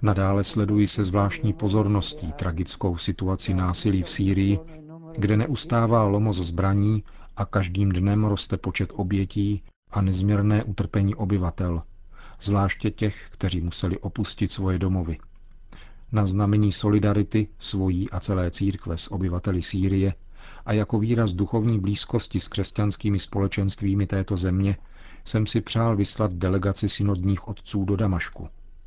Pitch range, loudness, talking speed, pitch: 95-105 Hz, -25 LUFS, 125 wpm, 100 Hz